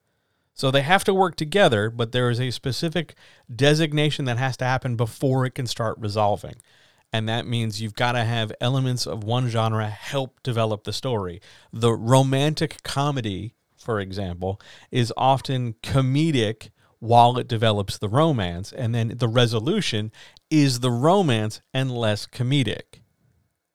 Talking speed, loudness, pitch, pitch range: 150 wpm, -23 LUFS, 120 Hz, 110-135 Hz